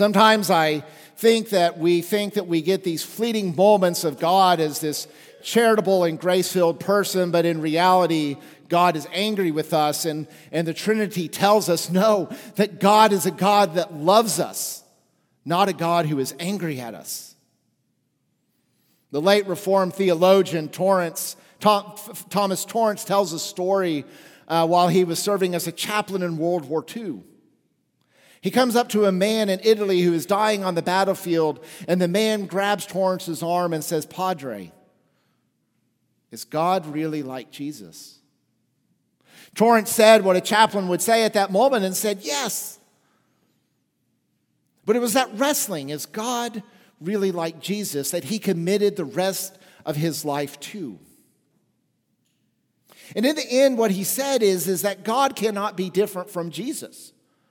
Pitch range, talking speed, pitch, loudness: 165-205 Hz, 155 wpm, 185 Hz, -21 LUFS